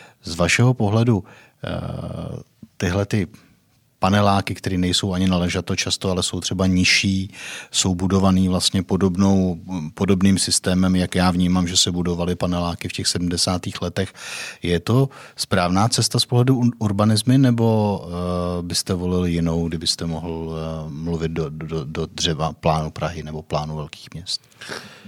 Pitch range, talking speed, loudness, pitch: 85-100 Hz, 135 wpm, -20 LUFS, 90 Hz